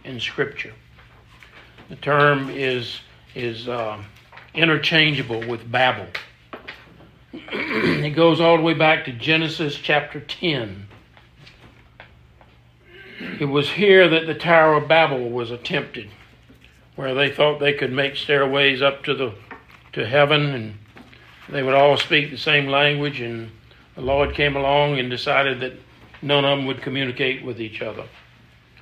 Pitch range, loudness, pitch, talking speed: 120-145 Hz, -19 LUFS, 140 Hz, 135 wpm